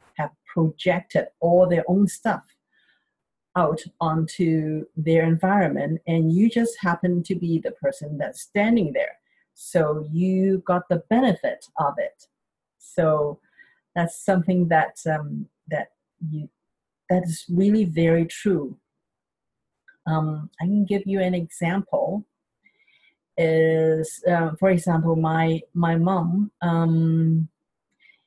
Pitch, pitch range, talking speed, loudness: 170 Hz, 160-195 Hz, 120 wpm, -23 LUFS